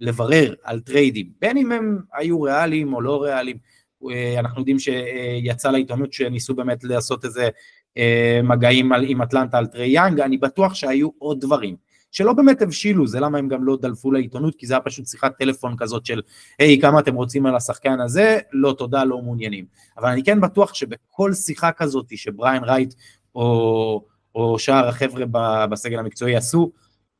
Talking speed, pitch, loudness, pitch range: 165 wpm, 130 Hz, -19 LUFS, 120-145 Hz